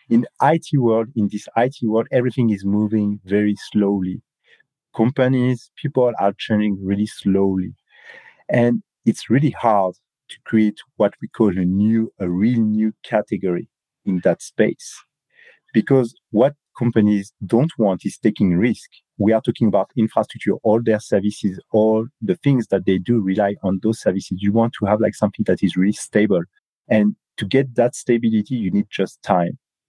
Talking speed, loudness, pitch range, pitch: 165 wpm, -19 LUFS, 100-120 Hz, 110 Hz